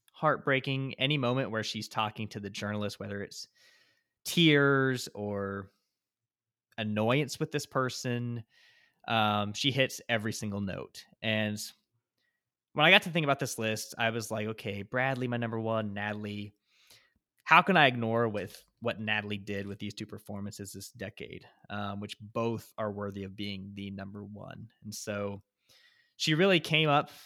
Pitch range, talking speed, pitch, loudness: 105-130 Hz, 155 wpm, 110 Hz, -30 LUFS